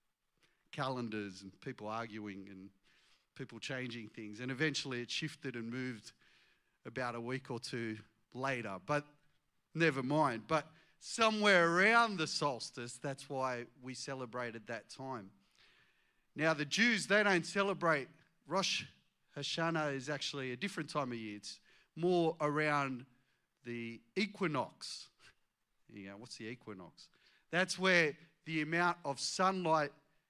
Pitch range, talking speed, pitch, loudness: 120-160 Hz, 125 wpm, 140 Hz, -36 LUFS